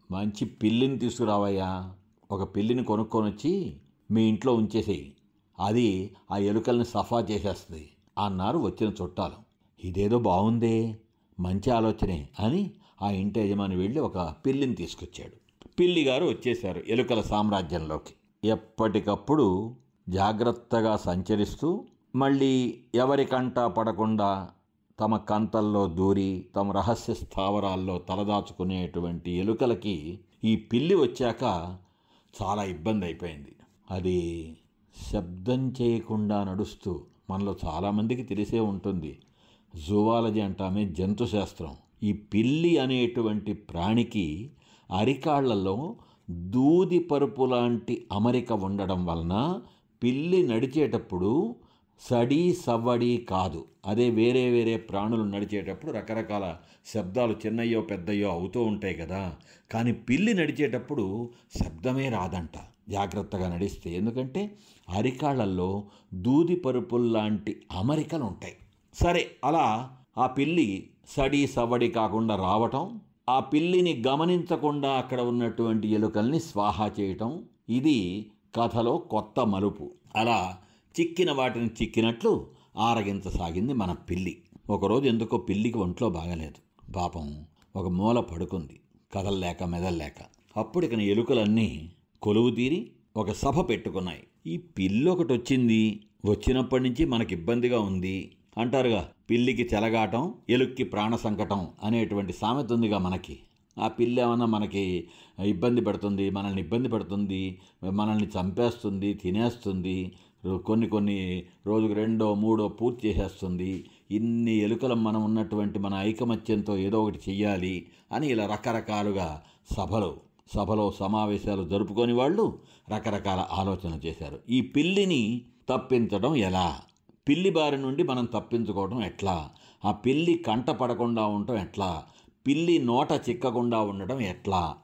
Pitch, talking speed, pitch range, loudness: 105 Hz, 100 wpm, 95-120 Hz, -28 LUFS